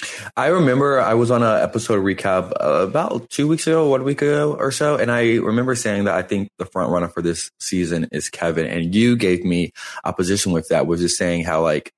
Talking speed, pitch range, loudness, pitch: 225 wpm, 90-130 Hz, -19 LUFS, 100 Hz